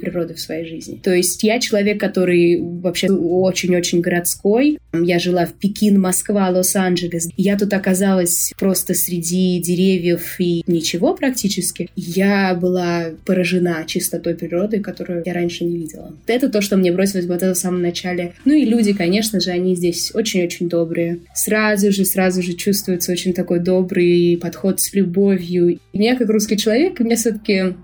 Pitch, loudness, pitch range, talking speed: 180 Hz, -17 LUFS, 175-200 Hz, 160 wpm